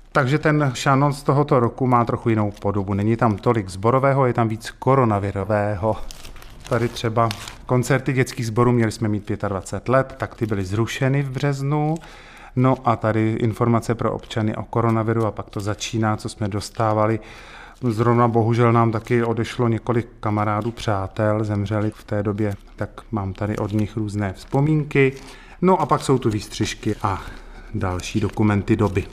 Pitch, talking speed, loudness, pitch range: 115 Hz, 160 wpm, -21 LUFS, 105-125 Hz